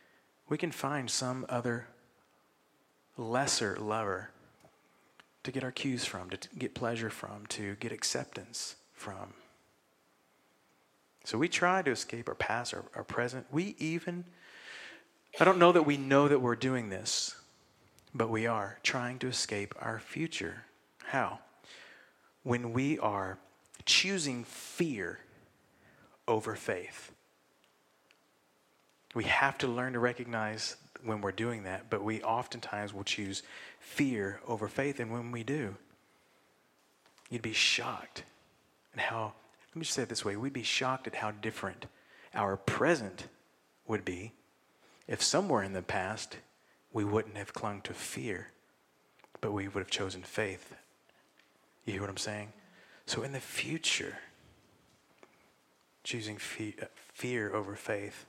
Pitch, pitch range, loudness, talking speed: 115 Hz, 100-130 Hz, -34 LUFS, 140 wpm